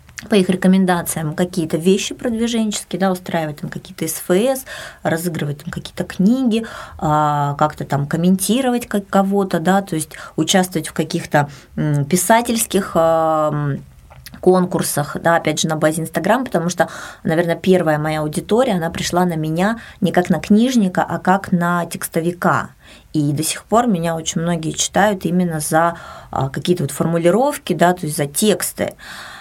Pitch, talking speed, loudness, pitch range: 175 Hz, 140 wpm, -18 LUFS, 160-195 Hz